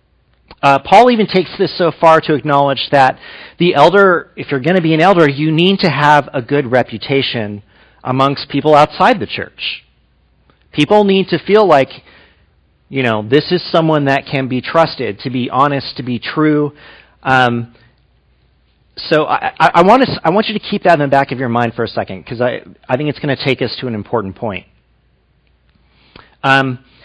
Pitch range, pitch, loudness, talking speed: 125-160 Hz, 140 Hz, -13 LUFS, 190 wpm